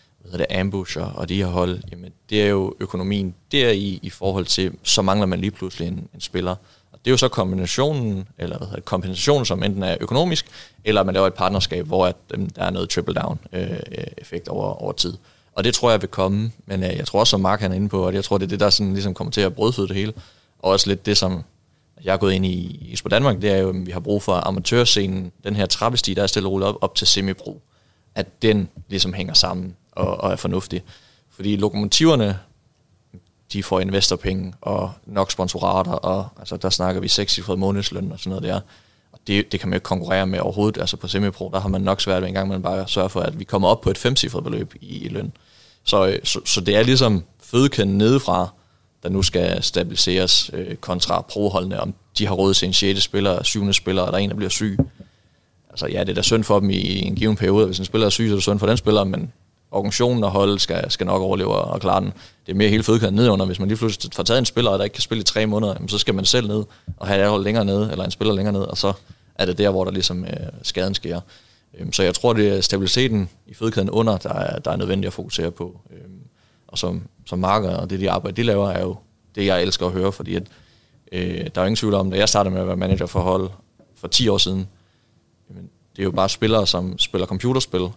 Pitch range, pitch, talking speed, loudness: 95-105 Hz, 95 Hz, 250 wpm, -20 LUFS